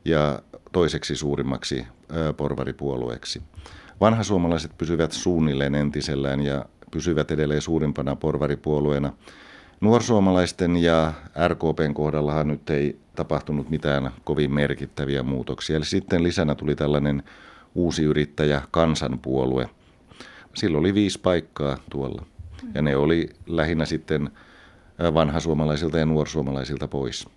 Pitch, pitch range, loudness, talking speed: 75 Hz, 70-80 Hz, -24 LUFS, 105 wpm